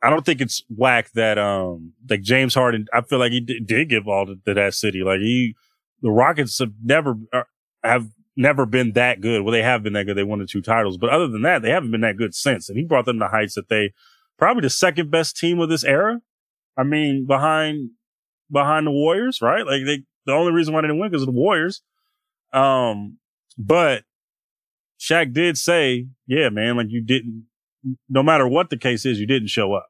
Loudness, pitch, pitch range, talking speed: -19 LUFS, 125 Hz, 110-150 Hz, 225 wpm